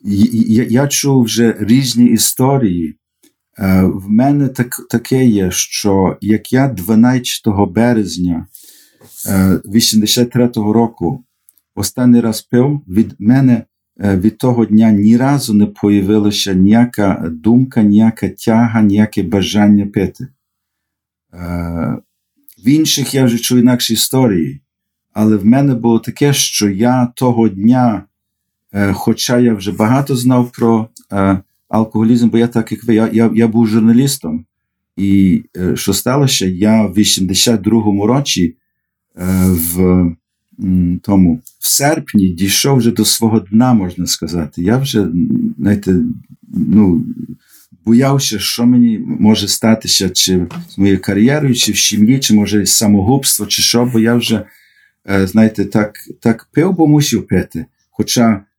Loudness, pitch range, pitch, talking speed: -12 LUFS, 100-120 Hz, 110 Hz, 130 wpm